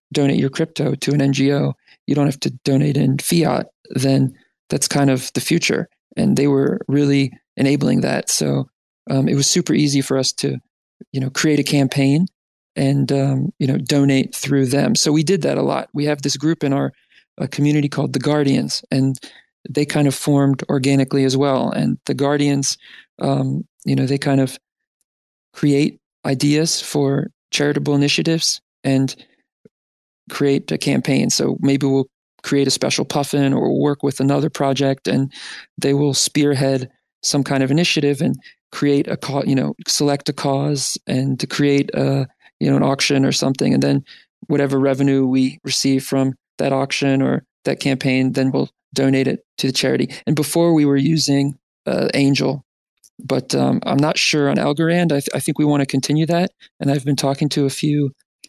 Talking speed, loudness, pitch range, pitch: 180 wpm, -18 LUFS, 135-145 Hz, 140 Hz